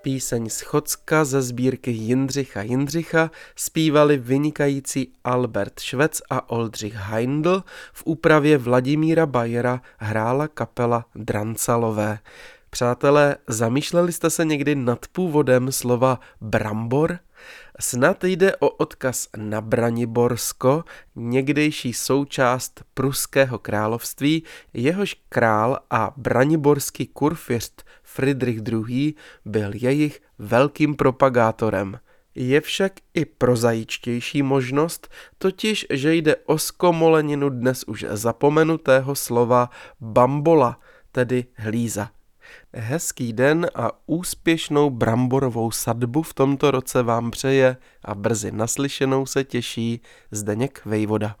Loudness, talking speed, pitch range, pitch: -21 LUFS, 100 wpm, 115-150 Hz, 130 Hz